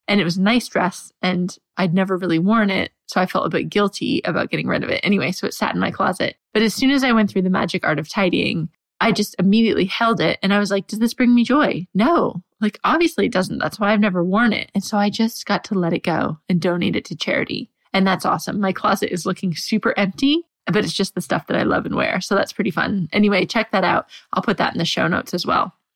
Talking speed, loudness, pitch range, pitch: 270 wpm, -19 LUFS, 185-225 Hz, 200 Hz